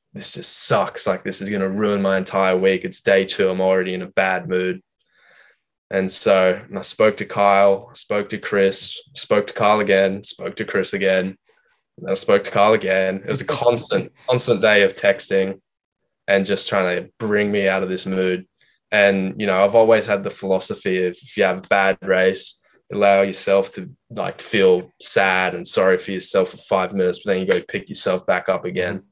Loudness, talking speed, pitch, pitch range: -19 LUFS, 205 wpm, 95 Hz, 95-105 Hz